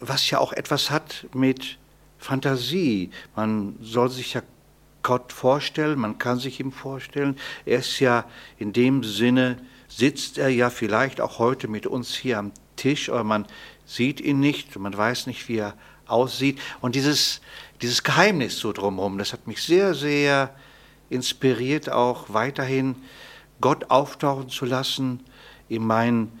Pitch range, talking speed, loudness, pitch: 115-135 Hz, 150 wpm, -24 LUFS, 125 Hz